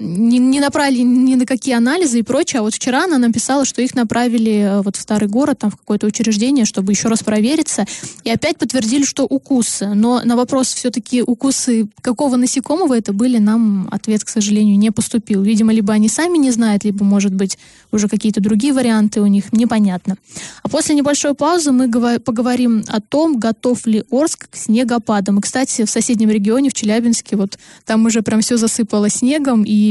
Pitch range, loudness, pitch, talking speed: 215-260 Hz, -15 LUFS, 235 Hz, 185 wpm